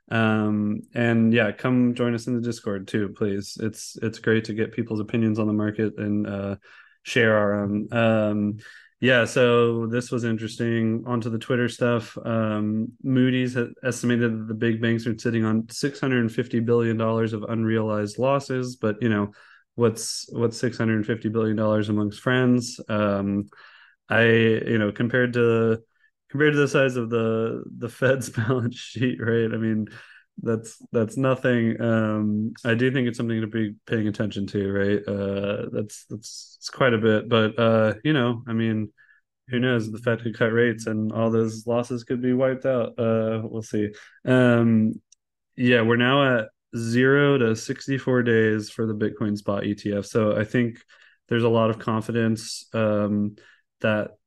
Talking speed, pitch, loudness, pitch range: 170 wpm, 115 Hz, -23 LUFS, 110-120 Hz